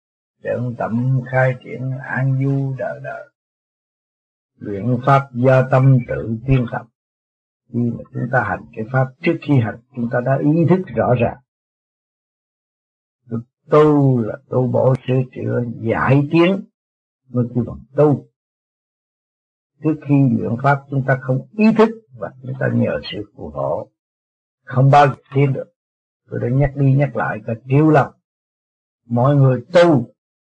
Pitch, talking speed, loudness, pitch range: 130 Hz, 150 wpm, -17 LUFS, 115-140 Hz